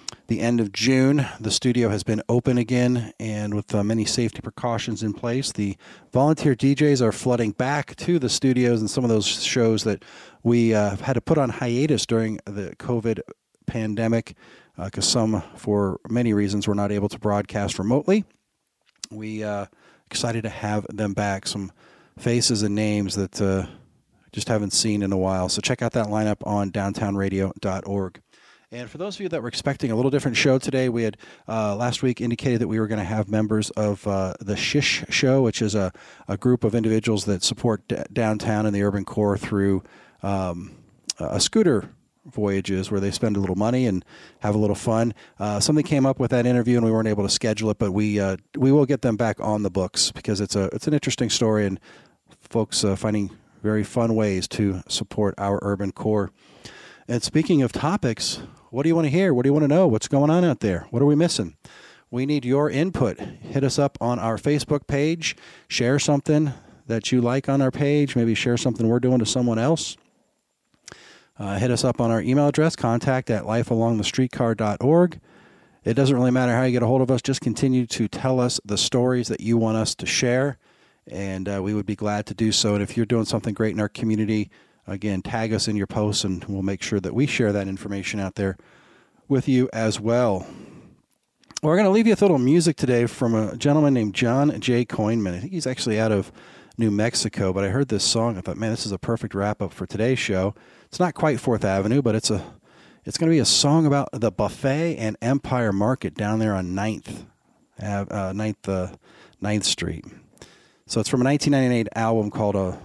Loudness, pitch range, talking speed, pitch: -23 LUFS, 105-130 Hz, 210 wpm, 115 Hz